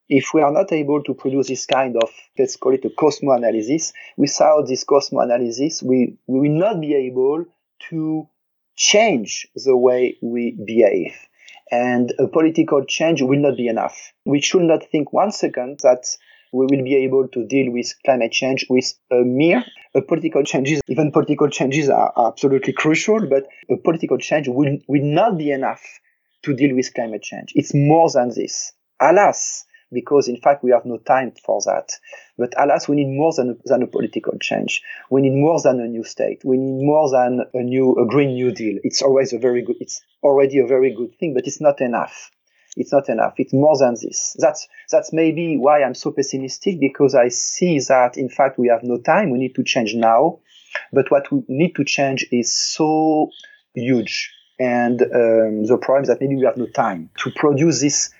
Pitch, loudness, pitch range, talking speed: 135 Hz, -18 LUFS, 125-155 Hz, 195 wpm